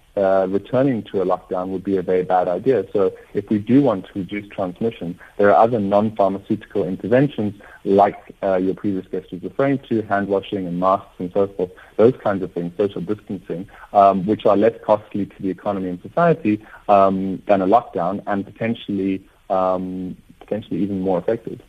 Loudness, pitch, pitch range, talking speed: -20 LUFS, 100 Hz, 95-105 Hz, 185 wpm